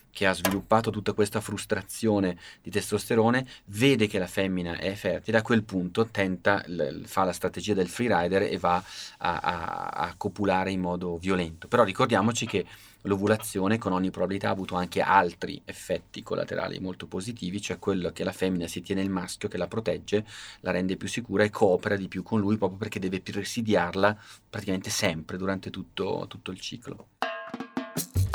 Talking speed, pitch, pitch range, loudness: 170 wpm, 100 Hz, 95-105 Hz, -28 LUFS